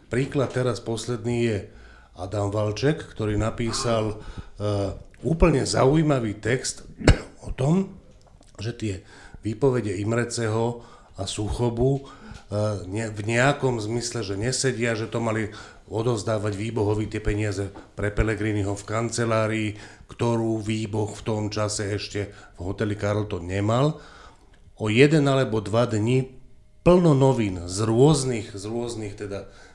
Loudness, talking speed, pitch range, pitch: -25 LUFS, 120 wpm, 105-120 Hz, 110 Hz